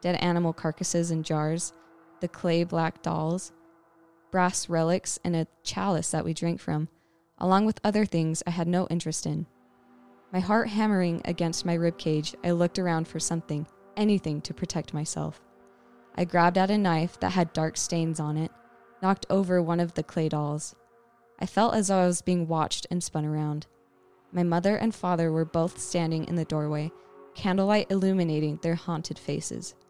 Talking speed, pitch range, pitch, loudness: 175 wpm, 160-180 Hz, 170 Hz, -28 LUFS